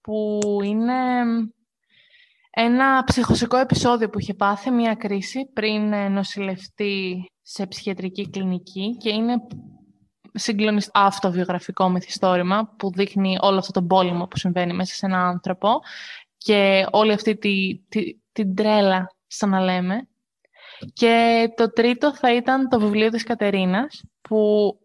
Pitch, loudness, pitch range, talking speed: 205 Hz, -21 LUFS, 190-230 Hz, 130 wpm